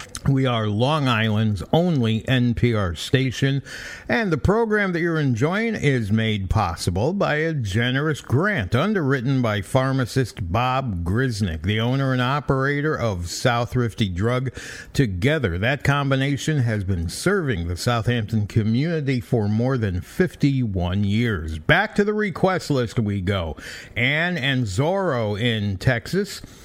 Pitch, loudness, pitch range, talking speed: 125 Hz, -22 LUFS, 110-140 Hz, 130 wpm